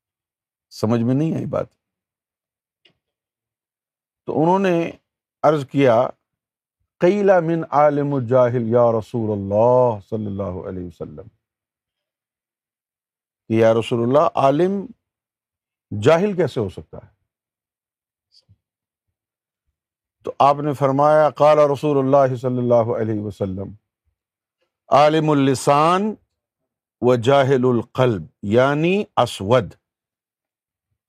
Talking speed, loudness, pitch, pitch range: 95 wpm, -18 LUFS, 120 Hz, 110-145 Hz